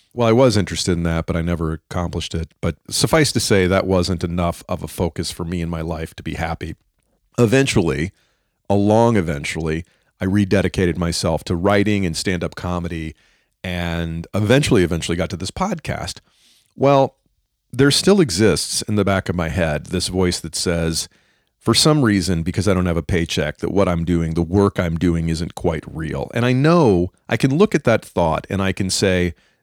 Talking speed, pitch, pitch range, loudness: 190 wpm, 90 Hz, 85-105 Hz, -19 LUFS